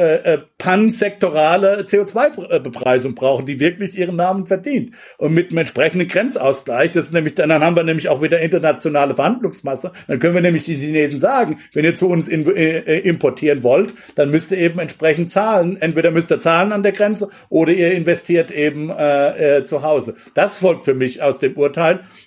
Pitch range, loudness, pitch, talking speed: 150-190 Hz, -16 LUFS, 170 Hz, 175 wpm